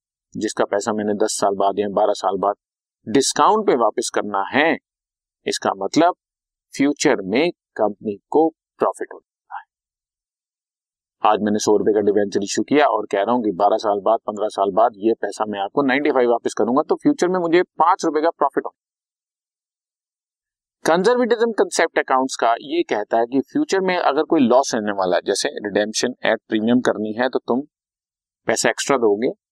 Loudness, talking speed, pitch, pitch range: -19 LUFS, 175 wpm, 120 Hz, 105-170 Hz